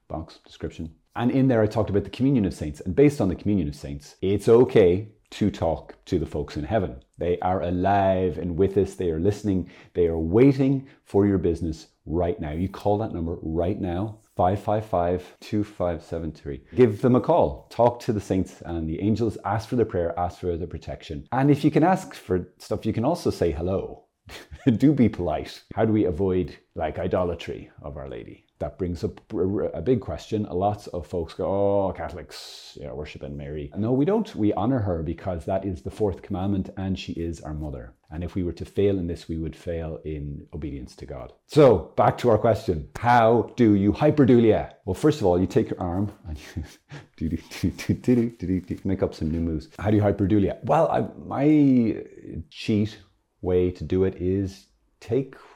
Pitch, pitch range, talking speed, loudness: 95 Hz, 85-105 Hz, 200 wpm, -24 LUFS